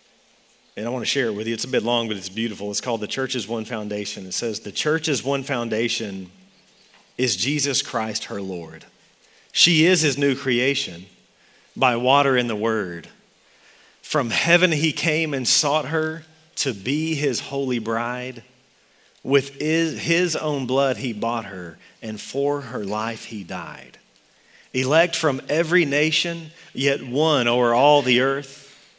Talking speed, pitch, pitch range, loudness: 160 wpm, 130 Hz, 115-150 Hz, -21 LUFS